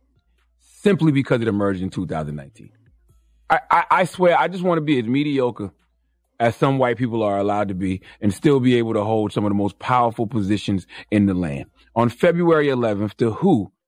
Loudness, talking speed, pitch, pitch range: -20 LUFS, 195 wpm, 110 Hz, 95-130 Hz